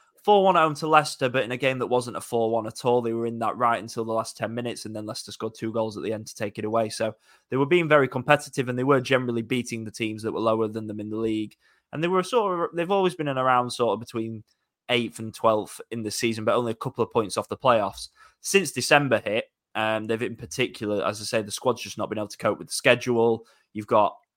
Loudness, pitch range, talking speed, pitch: -25 LUFS, 110-130 Hz, 265 wpm, 115 Hz